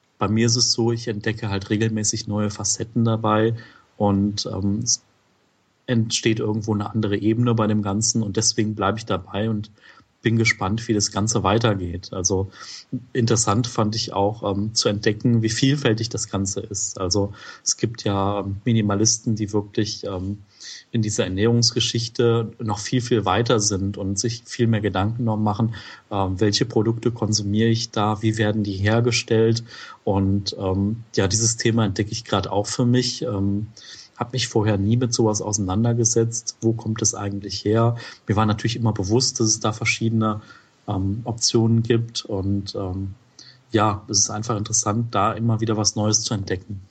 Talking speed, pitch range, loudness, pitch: 165 wpm, 100-115 Hz, -22 LUFS, 110 Hz